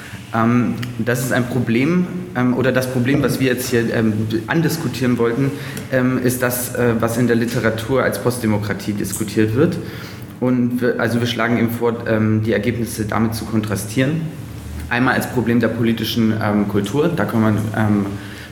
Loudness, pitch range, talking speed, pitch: -18 LUFS, 110-125 Hz, 145 wpm, 115 Hz